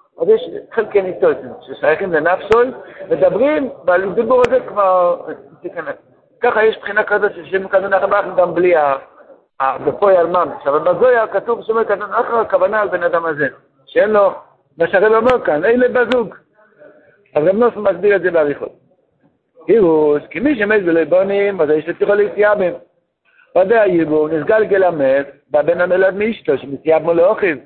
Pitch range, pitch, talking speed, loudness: 170-230 Hz, 200 Hz, 150 wpm, -15 LUFS